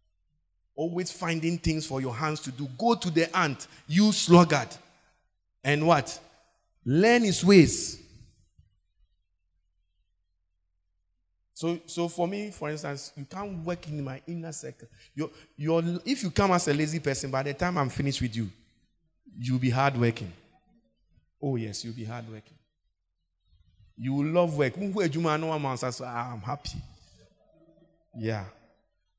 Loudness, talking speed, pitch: -27 LUFS, 130 wpm, 135 Hz